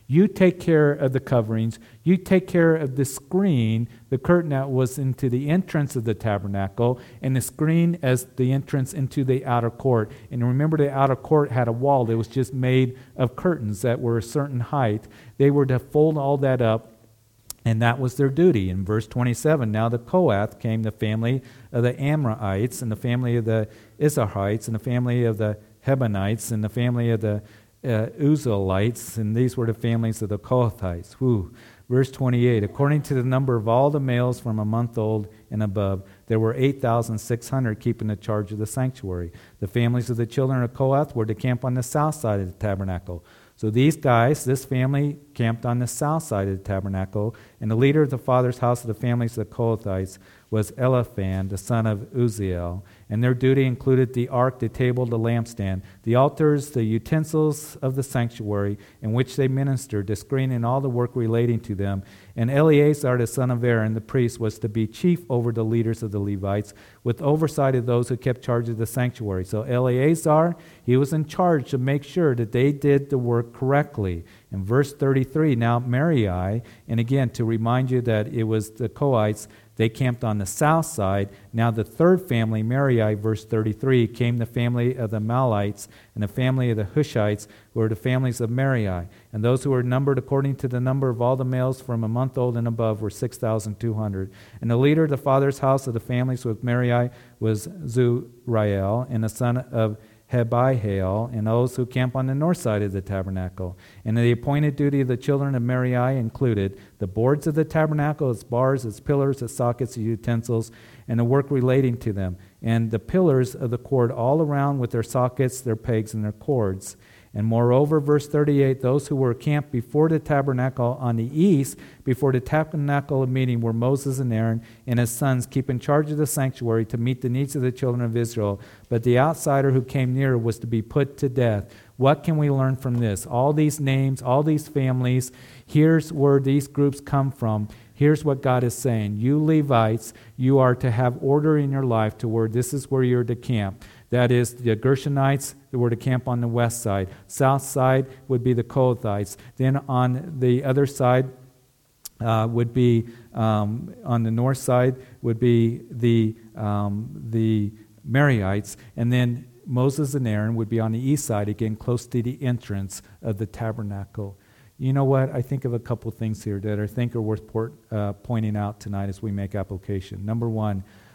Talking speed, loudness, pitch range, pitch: 200 wpm, -23 LUFS, 110-135 Hz, 120 Hz